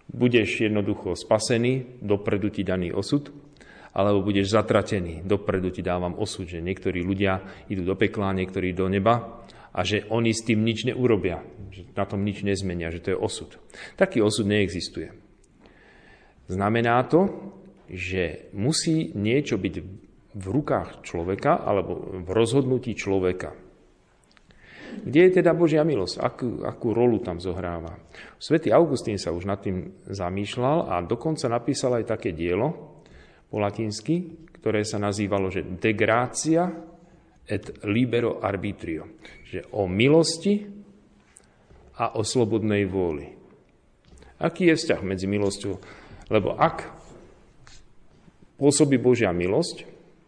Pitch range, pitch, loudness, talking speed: 95-125 Hz, 105 Hz, -25 LUFS, 125 wpm